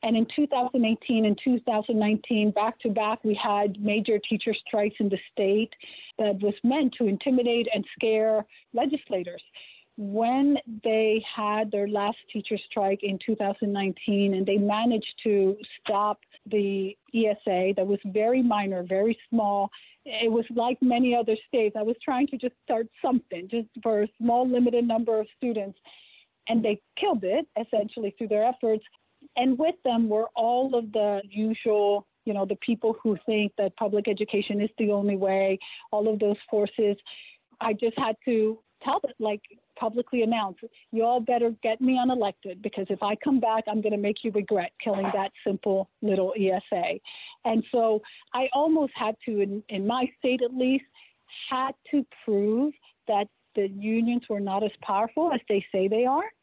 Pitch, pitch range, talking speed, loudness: 220 Hz, 205-240 Hz, 165 wpm, -26 LUFS